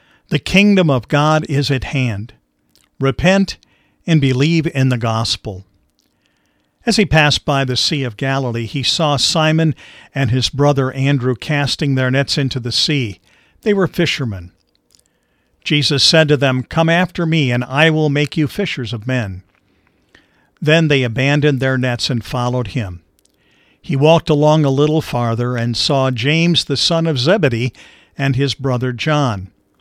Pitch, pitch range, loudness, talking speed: 135 Hz, 120-155 Hz, -15 LUFS, 155 wpm